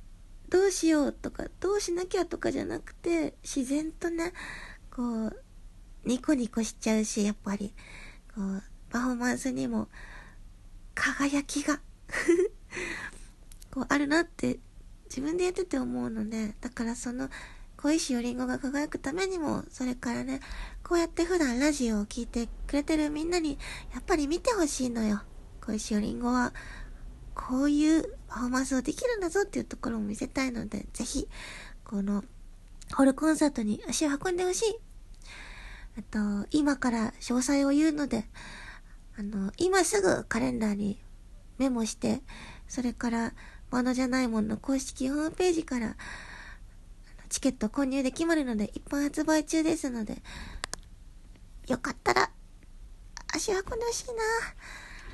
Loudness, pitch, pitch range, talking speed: -30 LUFS, 270 Hz, 235-320 Hz, 295 characters per minute